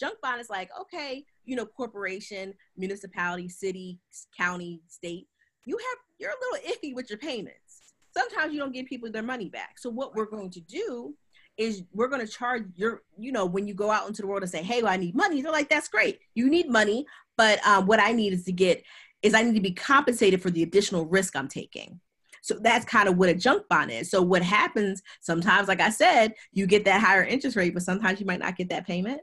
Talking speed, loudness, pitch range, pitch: 235 wpm, -25 LUFS, 185-255 Hz, 210 Hz